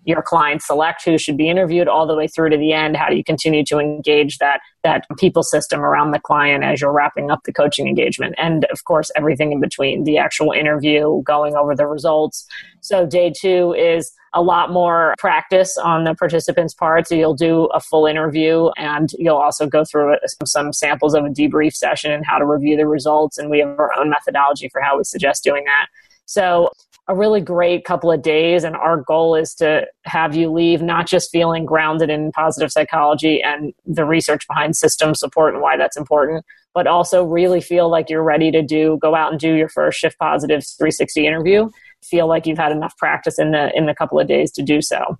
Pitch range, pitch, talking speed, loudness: 150-165 Hz, 155 Hz, 215 wpm, -16 LUFS